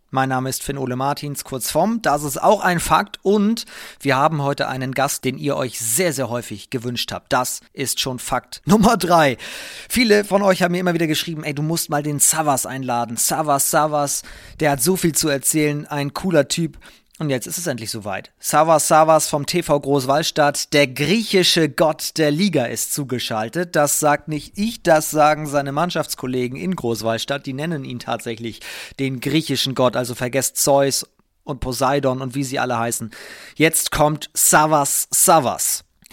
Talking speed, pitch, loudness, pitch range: 180 wpm, 145 Hz, -19 LUFS, 130-160 Hz